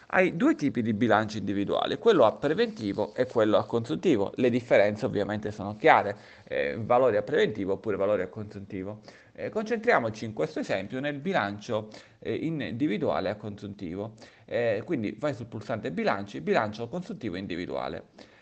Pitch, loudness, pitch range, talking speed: 115 Hz, -28 LUFS, 105-170 Hz, 155 wpm